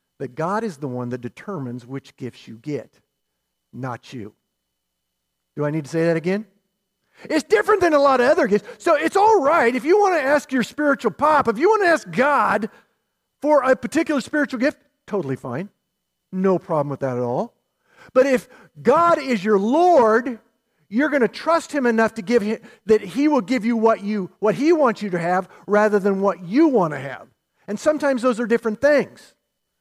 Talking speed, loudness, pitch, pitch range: 200 wpm, -19 LUFS, 225 Hz, 180-285 Hz